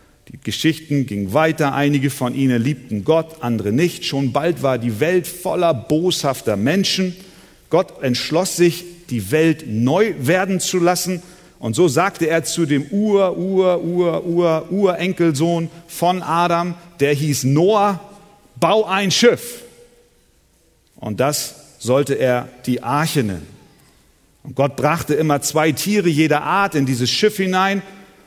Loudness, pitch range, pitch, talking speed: -18 LUFS, 140-180 Hz, 160 Hz, 130 wpm